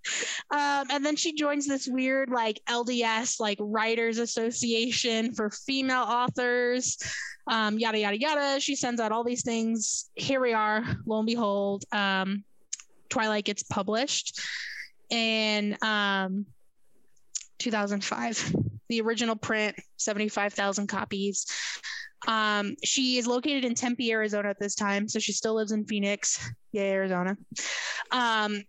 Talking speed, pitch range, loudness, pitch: 130 wpm, 205-245 Hz, -28 LUFS, 225 Hz